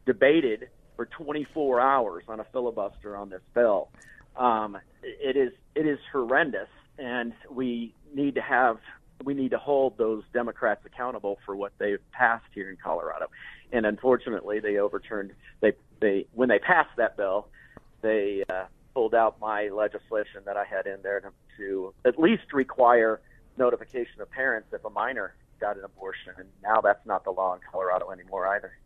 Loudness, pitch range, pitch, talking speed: -27 LUFS, 105-140 Hz, 120 Hz, 170 wpm